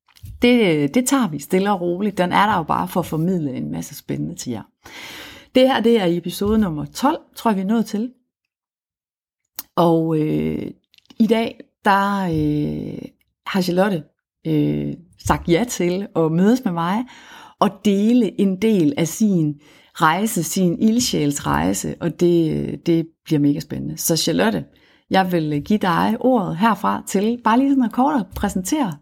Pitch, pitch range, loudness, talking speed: 185 Hz, 160-225 Hz, -19 LUFS, 165 wpm